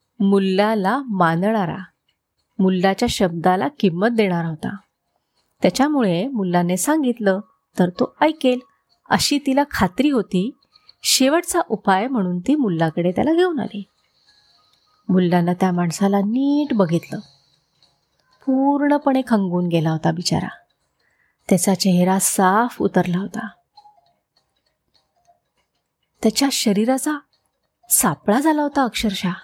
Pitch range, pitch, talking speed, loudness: 185-265 Hz, 205 Hz, 95 wpm, -19 LUFS